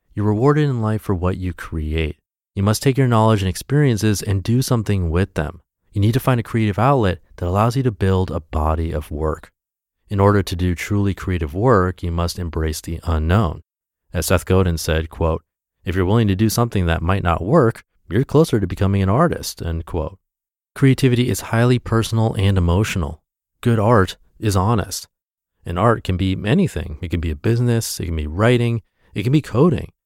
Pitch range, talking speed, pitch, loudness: 85-115 Hz, 200 wpm, 95 Hz, -19 LUFS